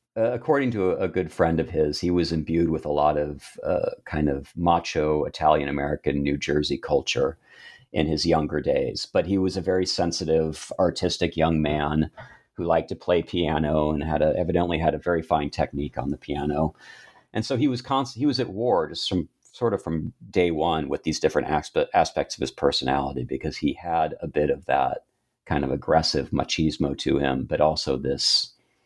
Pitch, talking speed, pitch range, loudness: 80 Hz, 195 wpm, 75-85 Hz, -25 LUFS